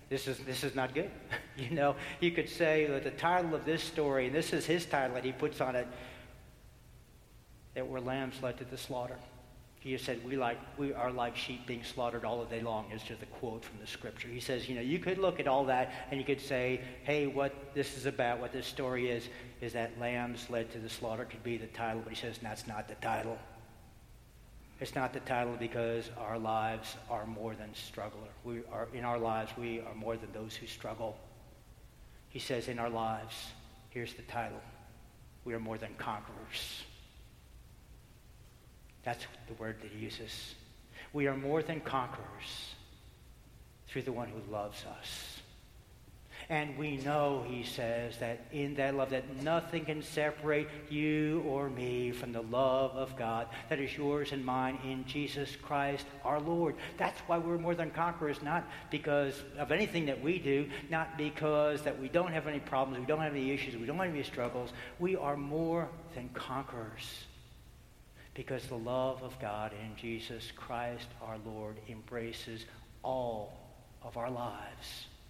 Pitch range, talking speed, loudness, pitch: 115-140 Hz, 185 wpm, -37 LUFS, 125 Hz